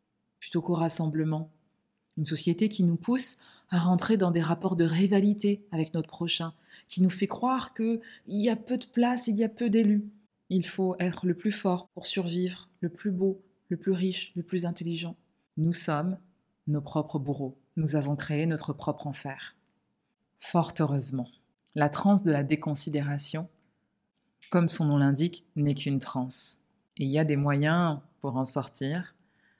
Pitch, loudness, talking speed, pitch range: 170 Hz, -29 LUFS, 170 wpm, 155-195 Hz